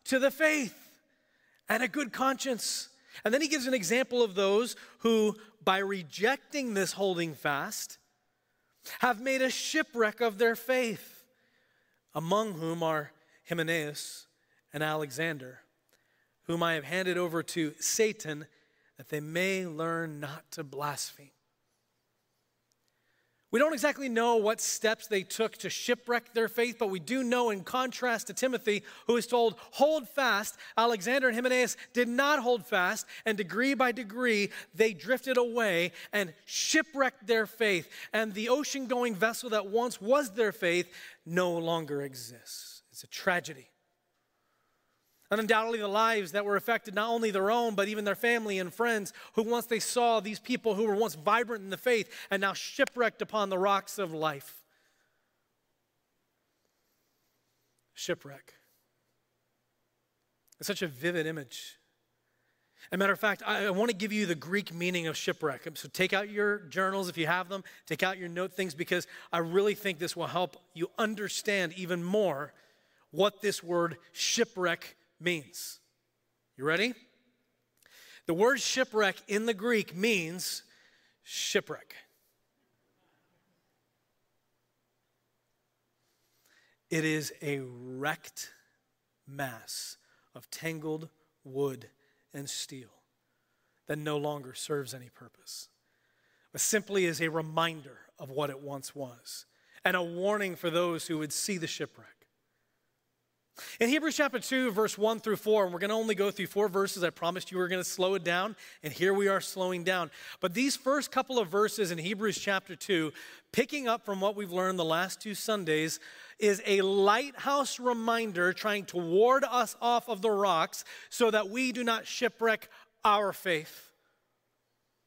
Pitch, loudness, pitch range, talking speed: 200 Hz, -30 LUFS, 170-230 Hz, 150 wpm